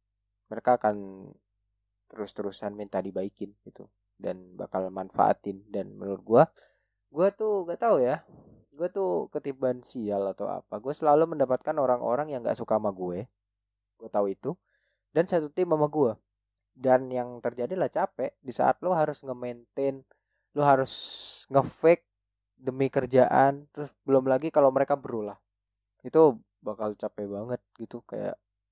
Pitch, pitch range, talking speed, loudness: 115 Hz, 100-140 Hz, 140 wpm, -28 LUFS